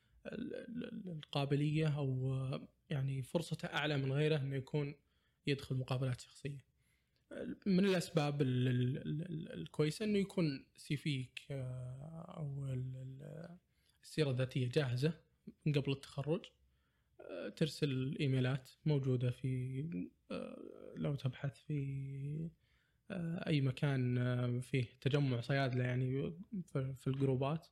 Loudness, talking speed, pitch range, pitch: -39 LUFS, 85 wpm, 130-155 Hz, 140 Hz